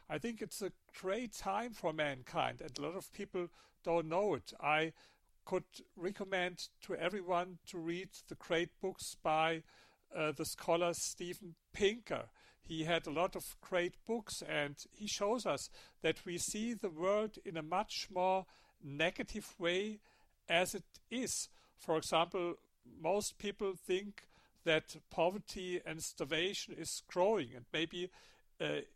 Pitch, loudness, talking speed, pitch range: 180 Hz, -39 LUFS, 145 wpm, 165-200 Hz